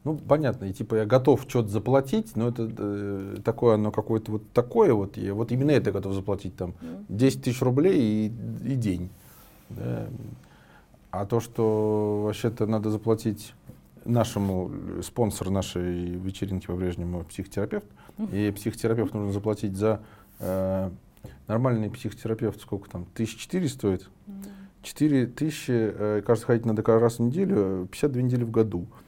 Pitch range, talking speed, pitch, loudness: 100-120 Hz, 145 wpm, 110 Hz, -27 LUFS